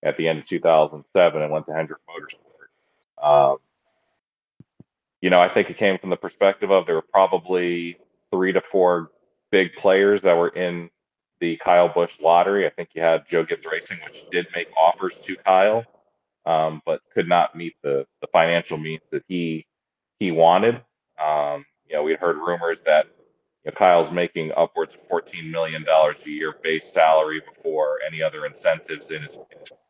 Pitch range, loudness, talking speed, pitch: 80-100 Hz, -21 LUFS, 175 wpm, 85 Hz